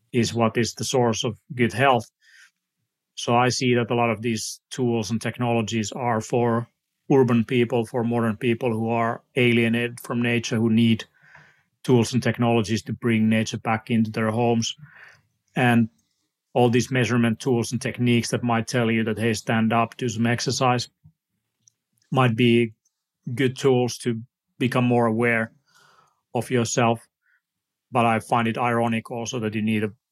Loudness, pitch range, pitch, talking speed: -23 LUFS, 115-125 Hz, 120 Hz, 160 wpm